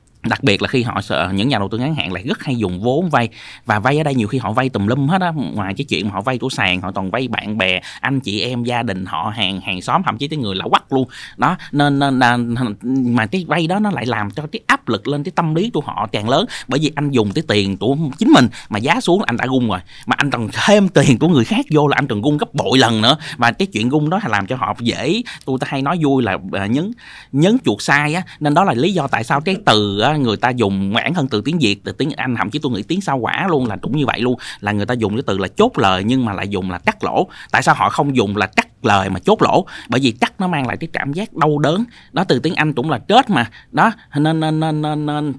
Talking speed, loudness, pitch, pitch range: 290 wpm, -17 LUFS, 130 Hz, 105-150 Hz